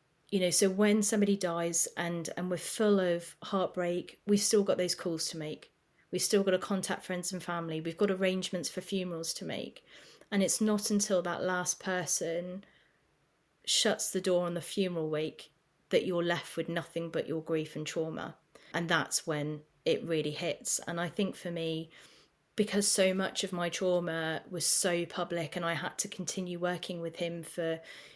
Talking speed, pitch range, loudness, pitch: 185 wpm, 165-190 Hz, -32 LUFS, 175 Hz